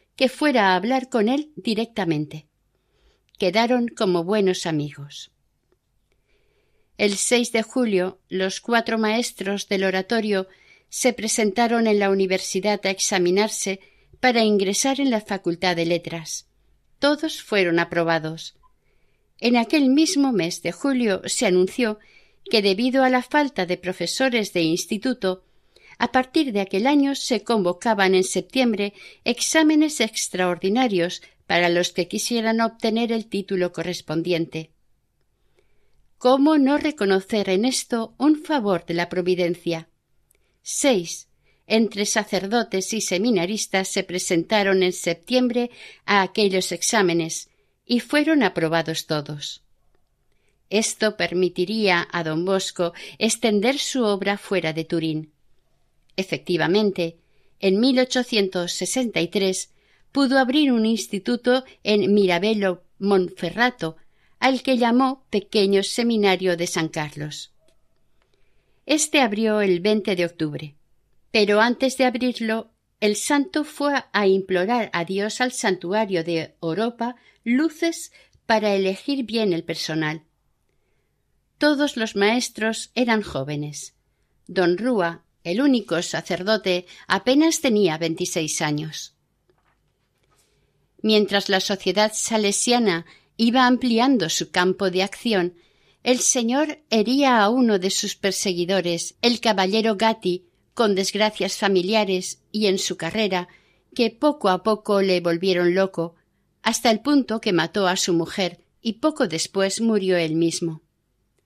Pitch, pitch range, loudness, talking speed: 200 Hz, 175-235 Hz, -21 LUFS, 115 wpm